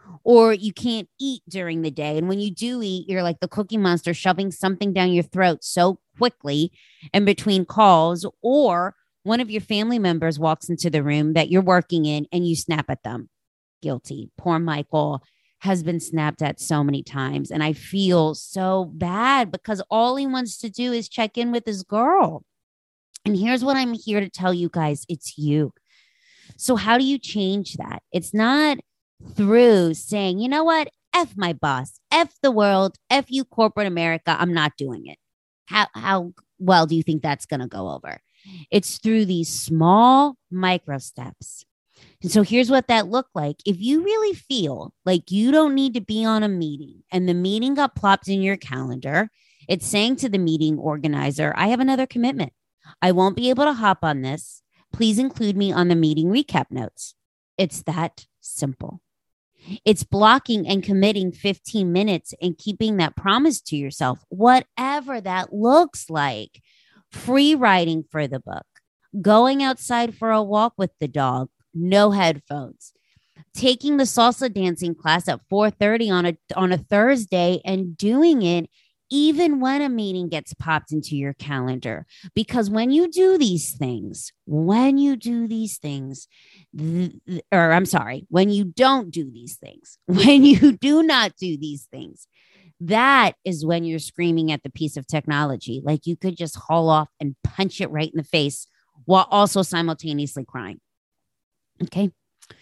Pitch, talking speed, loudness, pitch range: 185 Hz, 175 wpm, -20 LUFS, 160-225 Hz